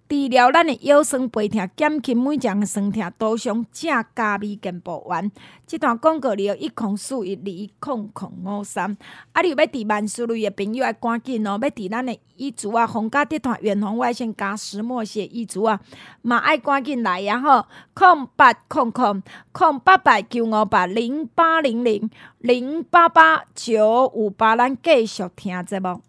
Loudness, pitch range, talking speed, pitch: -20 LUFS, 210-275 Hz, 250 characters per minute, 235 Hz